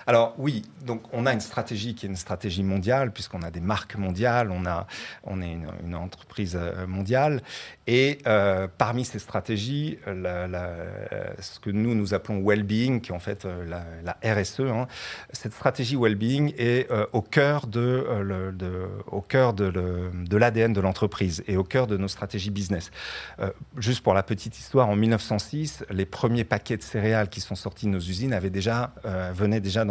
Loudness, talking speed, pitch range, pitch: -27 LUFS, 195 wpm, 95-120 Hz, 105 Hz